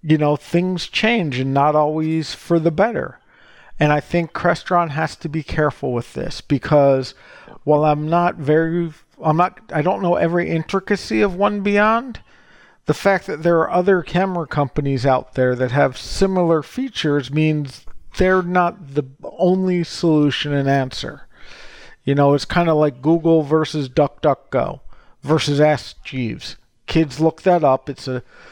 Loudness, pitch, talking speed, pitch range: -18 LUFS, 155 Hz, 160 wpm, 145-175 Hz